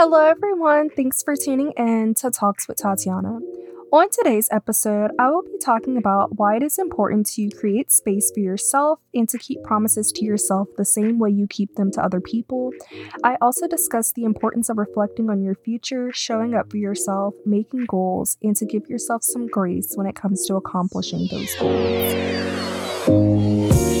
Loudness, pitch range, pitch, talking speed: -20 LUFS, 200-250 Hz, 215 Hz, 180 wpm